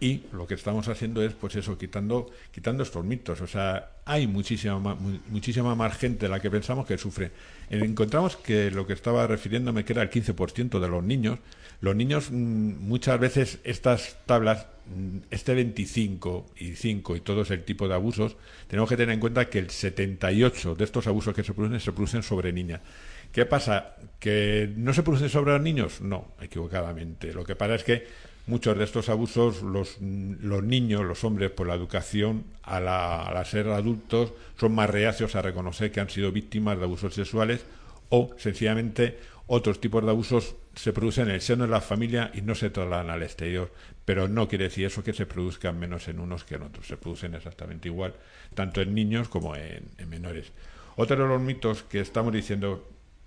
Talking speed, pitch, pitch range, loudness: 190 wpm, 105 Hz, 95-115 Hz, -28 LUFS